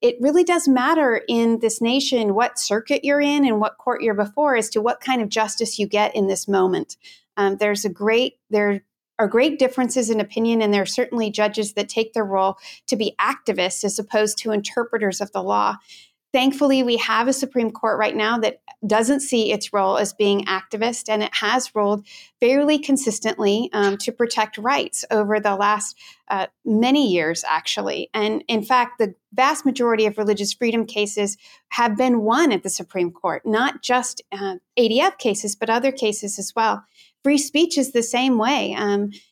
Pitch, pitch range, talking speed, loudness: 225 Hz, 210-255 Hz, 190 wpm, -20 LUFS